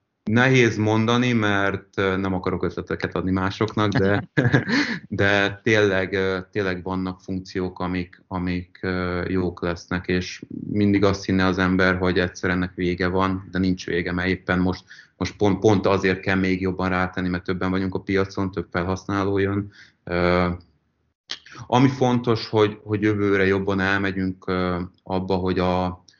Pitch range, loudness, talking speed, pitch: 90-100 Hz, -22 LUFS, 140 wpm, 95 Hz